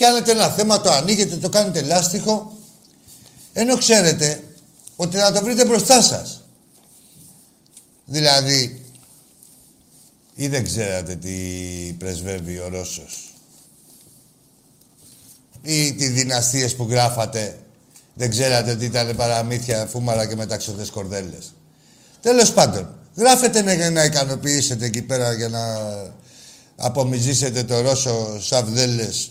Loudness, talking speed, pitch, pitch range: -19 LUFS, 105 wpm, 130 Hz, 110-165 Hz